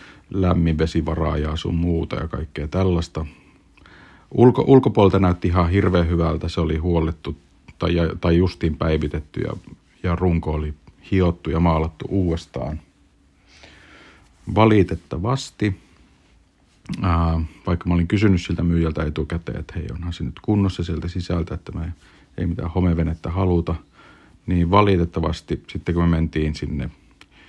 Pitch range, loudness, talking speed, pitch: 80-90 Hz, -21 LUFS, 130 wpm, 85 Hz